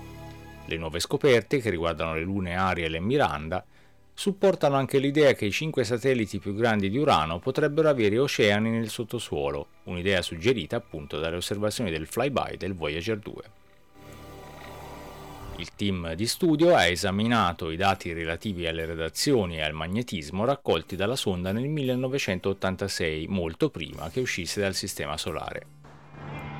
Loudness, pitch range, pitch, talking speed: -26 LUFS, 85-120 Hz, 100 Hz, 140 wpm